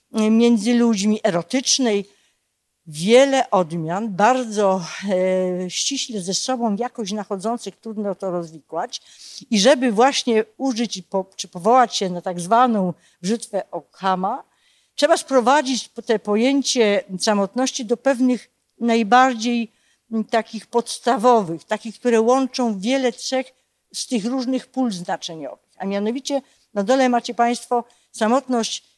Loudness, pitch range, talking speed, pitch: -20 LUFS, 200-250 Hz, 115 wpm, 230 Hz